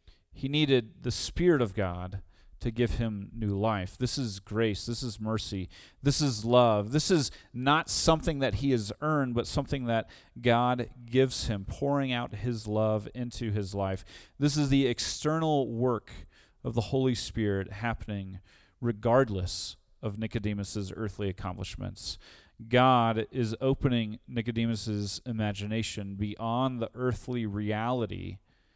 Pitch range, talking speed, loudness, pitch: 100-125 Hz, 135 wpm, -30 LUFS, 115 Hz